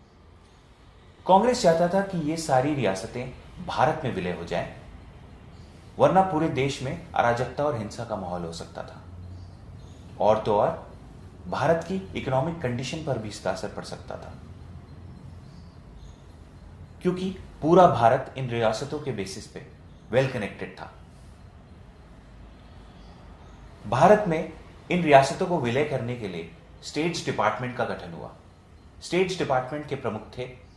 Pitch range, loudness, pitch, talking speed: 95-155 Hz, -25 LUFS, 125 Hz, 135 wpm